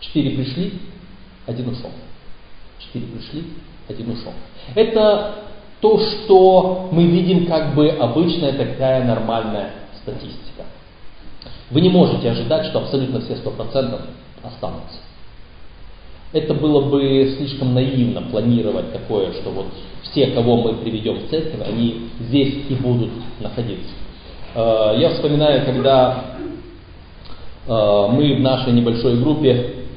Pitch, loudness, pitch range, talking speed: 130 Hz, -17 LUFS, 115-150 Hz, 115 wpm